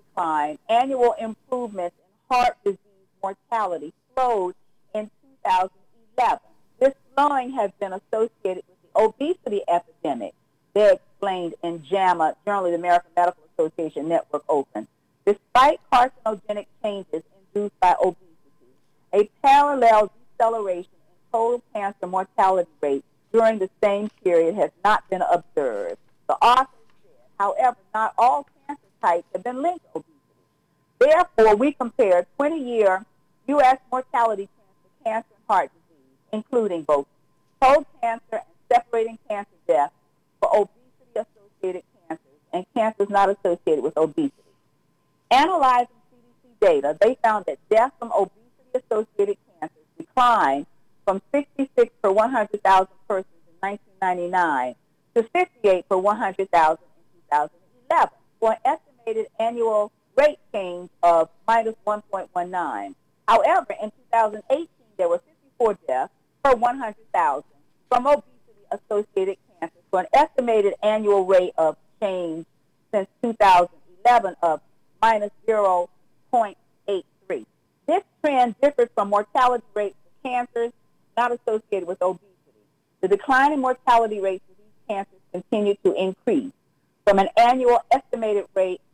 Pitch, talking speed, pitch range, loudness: 210 Hz, 115 wpm, 180-245 Hz, -22 LUFS